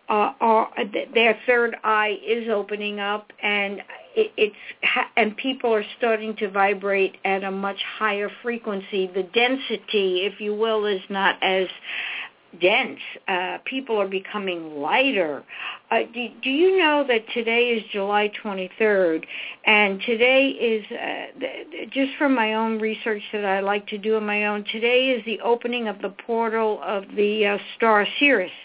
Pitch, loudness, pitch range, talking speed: 215 Hz, -22 LUFS, 200-235 Hz, 165 wpm